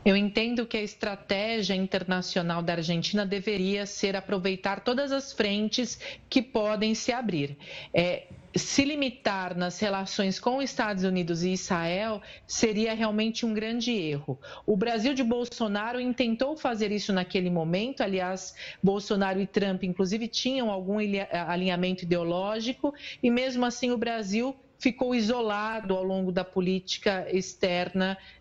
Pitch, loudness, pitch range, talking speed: 205 Hz, -28 LUFS, 185-235 Hz, 135 wpm